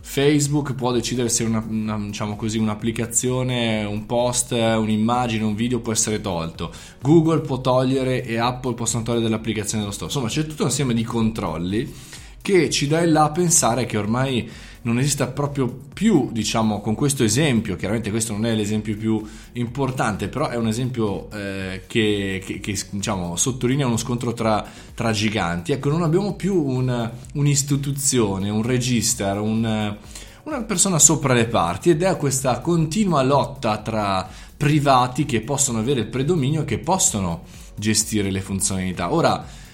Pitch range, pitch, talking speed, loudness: 105-135 Hz, 115 Hz, 160 wpm, -21 LUFS